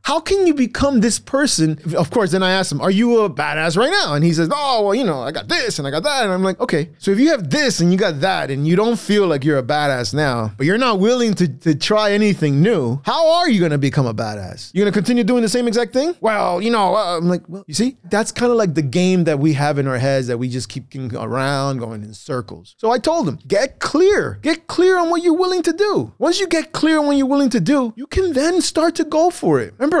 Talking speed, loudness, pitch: 285 wpm, -17 LUFS, 205 Hz